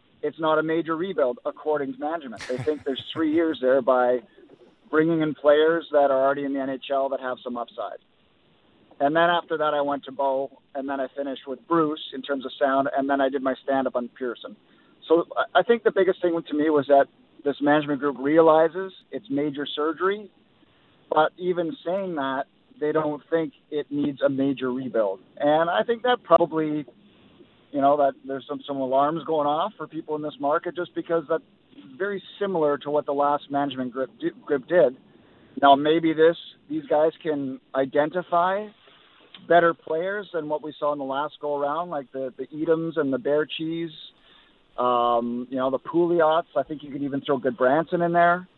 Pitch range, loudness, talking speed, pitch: 140-165 Hz, -24 LUFS, 195 wpm, 150 Hz